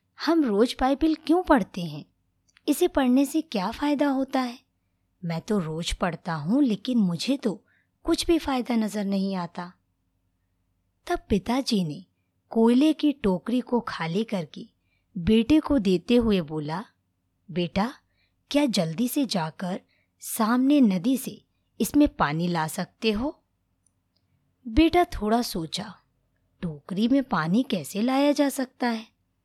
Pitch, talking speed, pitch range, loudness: 215 Hz, 130 wpm, 165-265 Hz, -25 LUFS